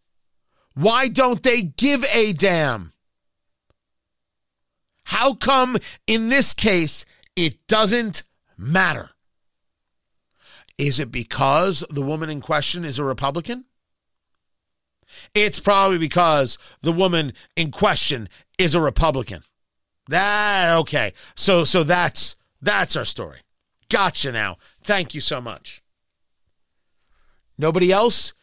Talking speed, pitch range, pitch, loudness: 105 wpm, 130-205 Hz, 165 Hz, -19 LUFS